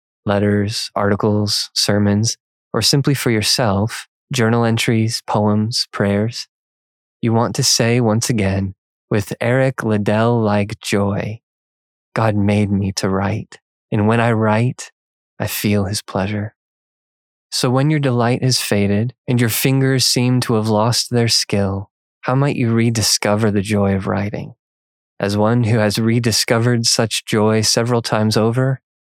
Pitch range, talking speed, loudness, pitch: 105-120 Hz, 140 wpm, -17 LUFS, 110 Hz